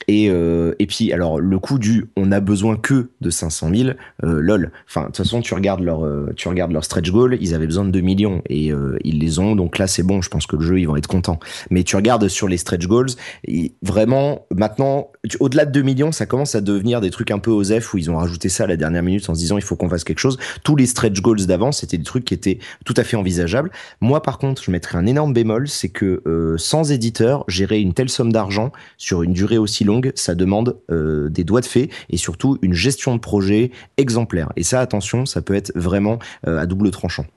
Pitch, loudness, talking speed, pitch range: 100 Hz, -18 LUFS, 255 wpm, 90-120 Hz